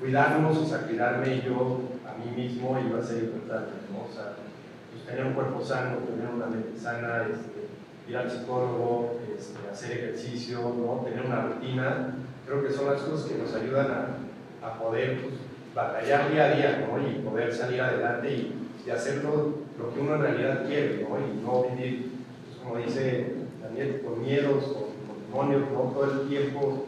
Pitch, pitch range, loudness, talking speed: 125 Hz, 120-140 Hz, -29 LUFS, 185 wpm